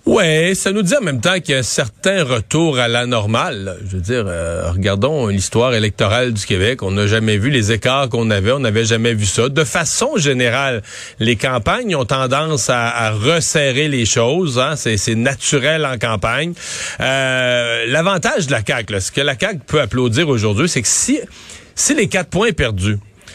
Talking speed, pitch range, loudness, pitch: 200 wpm, 110-150 Hz, -16 LUFS, 125 Hz